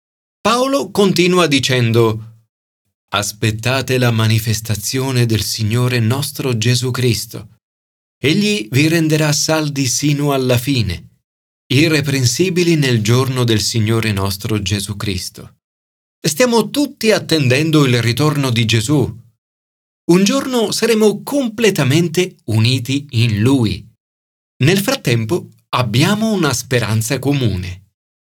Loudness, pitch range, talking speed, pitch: -15 LUFS, 110-155 Hz, 100 wpm, 125 Hz